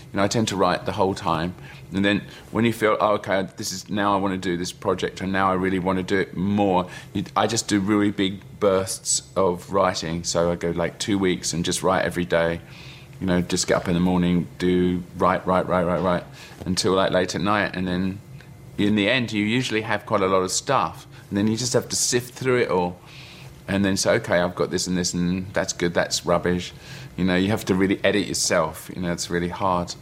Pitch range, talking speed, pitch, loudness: 90-105 Hz, 245 wpm, 95 Hz, -23 LUFS